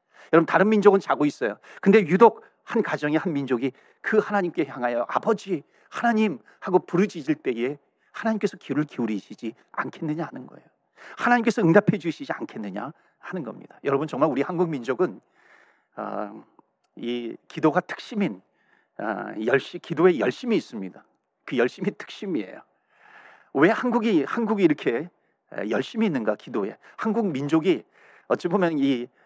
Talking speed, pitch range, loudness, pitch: 325 characters per minute, 150-220 Hz, -24 LUFS, 180 Hz